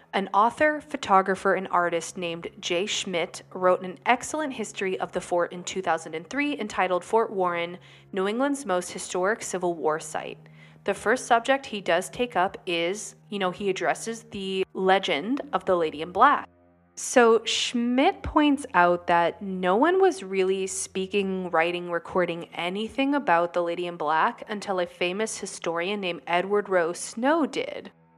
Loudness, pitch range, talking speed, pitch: -25 LUFS, 175-220 Hz, 155 wpm, 190 Hz